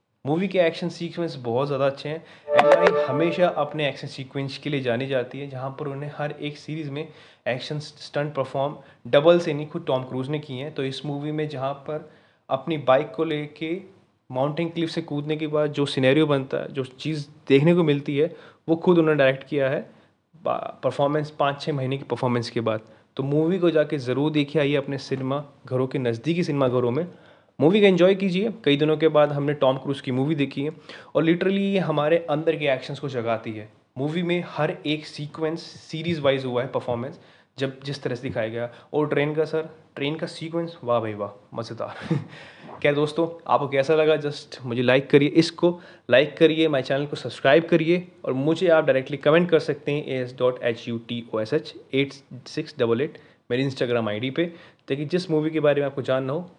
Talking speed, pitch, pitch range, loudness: 210 wpm, 145 Hz, 135-160 Hz, -24 LUFS